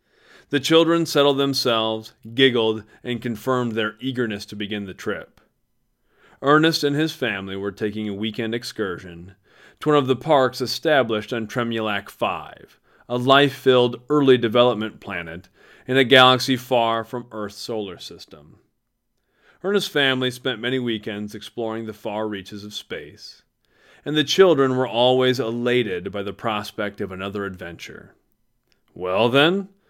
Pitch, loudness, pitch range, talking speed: 120 Hz, -21 LUFS, 105-130 Hz, 140 wpm